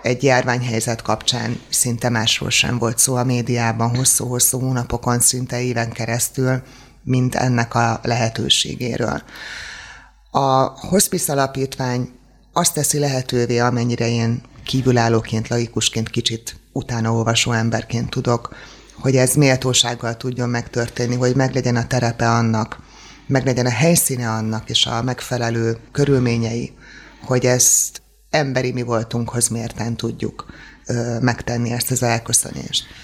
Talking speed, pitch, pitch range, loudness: 115 wpm, 120 Hz, 115-130 Hz, -18 LUFS